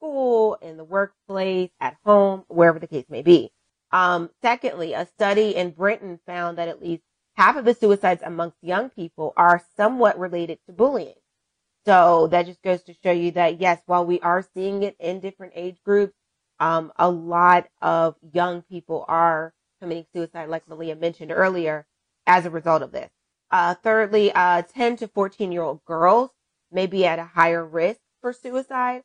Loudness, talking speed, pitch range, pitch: -21 LUFS, 180 wpm, 170-200 Hz, 180 Hz